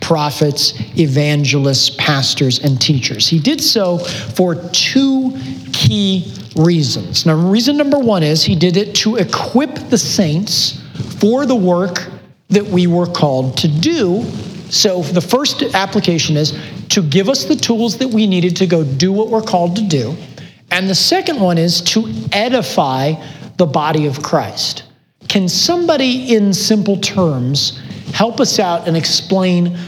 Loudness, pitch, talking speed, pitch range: -14 LUFS, 175 Hz, 150 wpm, 150-205 Hz